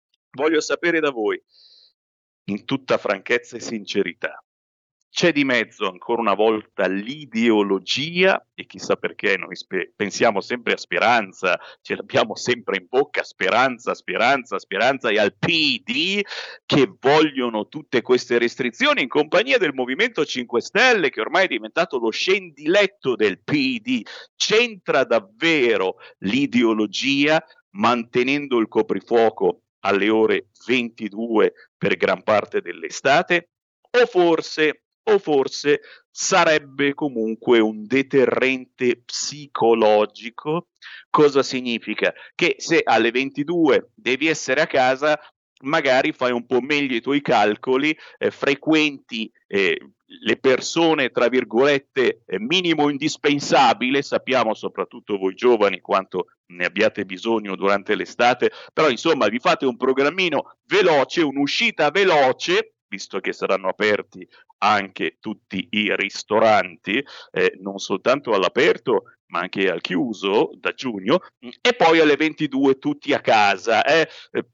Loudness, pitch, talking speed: -20 LUFS, 150 Hz, 120 wpm